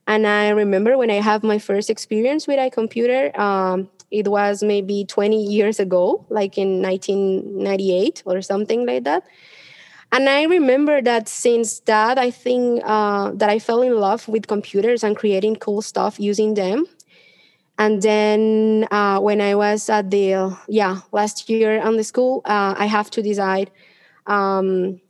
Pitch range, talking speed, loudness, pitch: 200-225 Hz, 165 wpm, -19 LUFS, 210 Hz